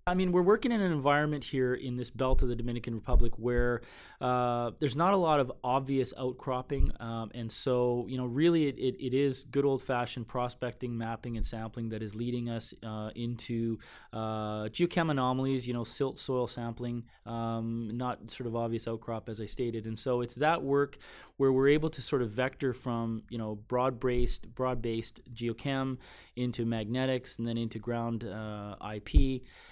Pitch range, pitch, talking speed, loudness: 115-130 Hz, 120 Hz, 180 wpm, -32 LUFS